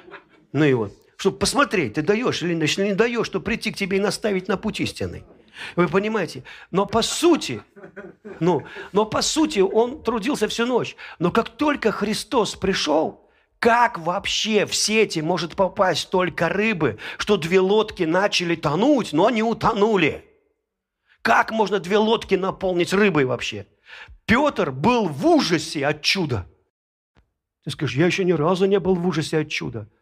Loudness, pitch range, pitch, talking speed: -21 LUFS, 175-220 Hz, 200 Hz, 155 wpm